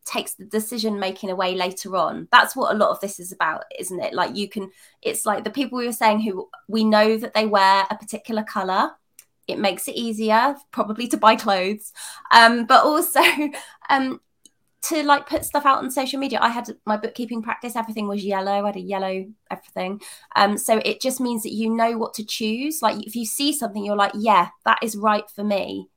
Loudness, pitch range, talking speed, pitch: -21 LUFS, 205-240 Hz, 215 wpm, 220 Hz